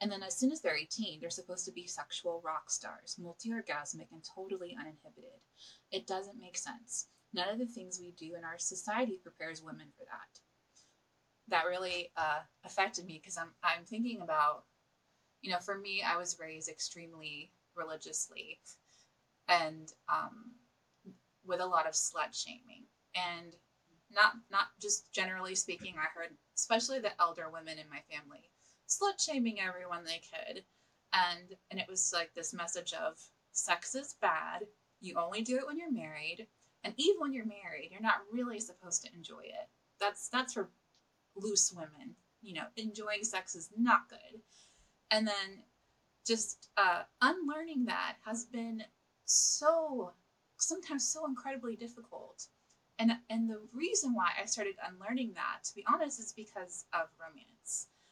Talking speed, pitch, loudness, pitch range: 160 wpm, 195 Hz, -36 LUFS, 170-235 Hz